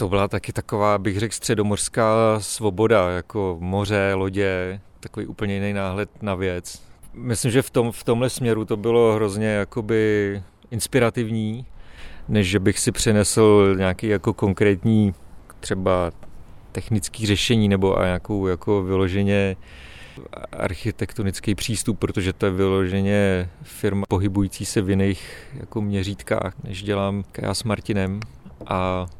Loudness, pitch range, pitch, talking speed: -22 LUFS, 95-110 Hz, 100 Hz, 130 wpm